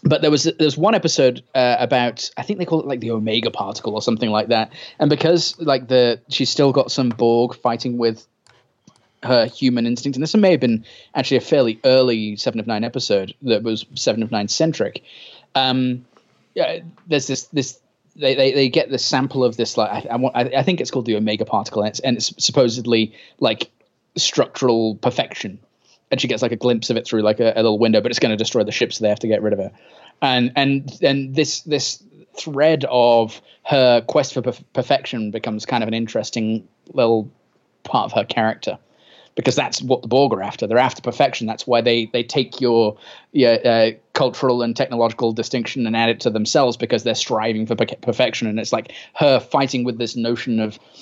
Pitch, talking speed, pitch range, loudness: 120 Hz, 215 wpm, 115-135 Hz, -19 LUFS